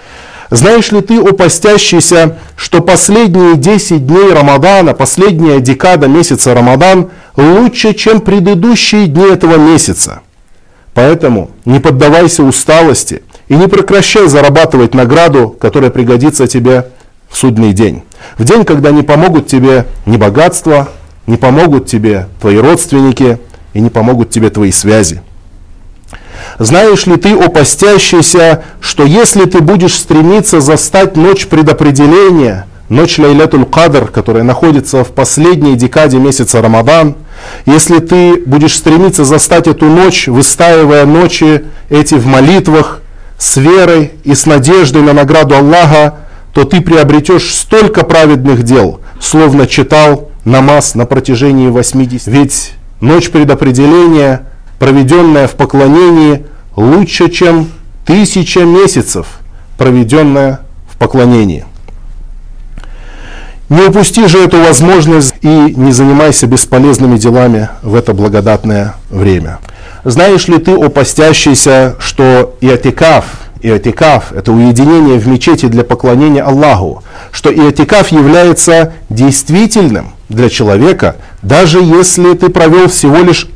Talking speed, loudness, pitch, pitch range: 115 wpm, -5 LUFS, 145 Hz, 125-170 Hz